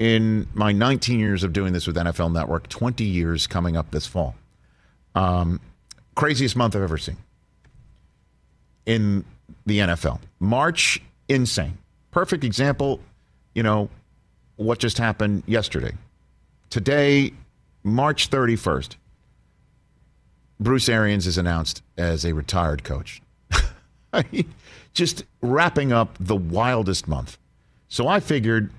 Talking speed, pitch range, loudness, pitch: 115 wpm, 85-120 Hz, -23 LUFS, 105 Hz